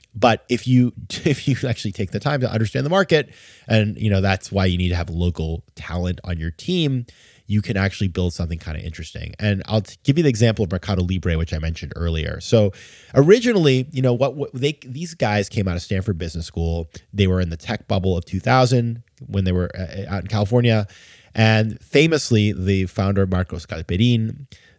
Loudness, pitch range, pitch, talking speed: -21 LUFS, 90-120 Hz, 105 Hz, 200 wpm